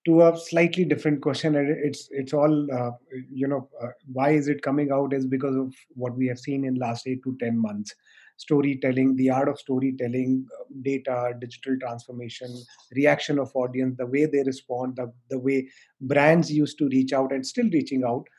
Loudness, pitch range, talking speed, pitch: -25 LUFS, 125-145 Hz, 185 wpm, 135 Hz